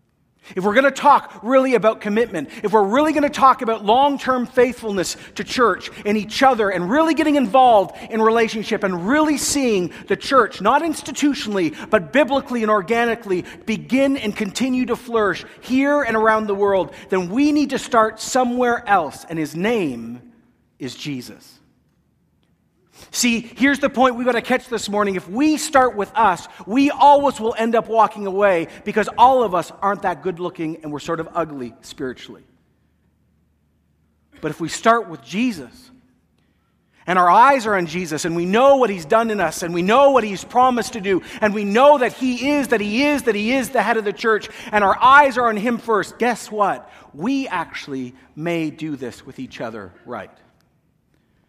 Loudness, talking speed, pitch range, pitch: -18 LUFS, 190 wpm, 190-255 Hz, 220 Hz